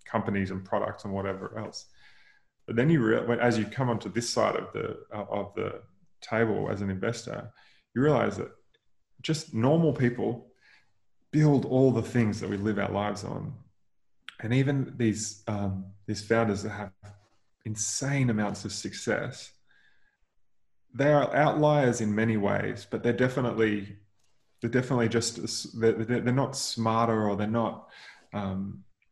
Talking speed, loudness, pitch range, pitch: 145 wpm, -28 LUFS, 105-125 Hz, 115 Hz